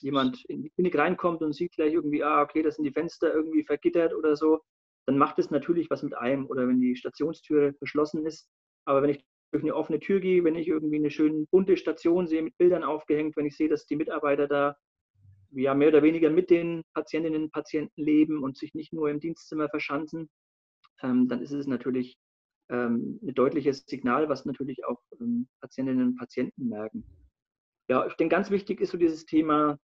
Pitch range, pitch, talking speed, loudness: 140-165 Hz, 150 Hz, 195 wpm, -27 LUFS